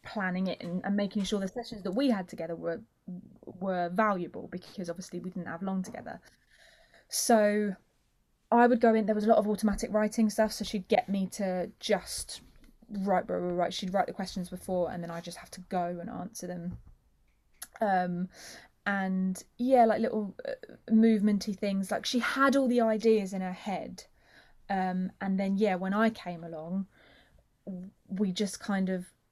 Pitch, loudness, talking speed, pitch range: 195 Hz, -30 LUFS, 180 wpm, 185-220 Hz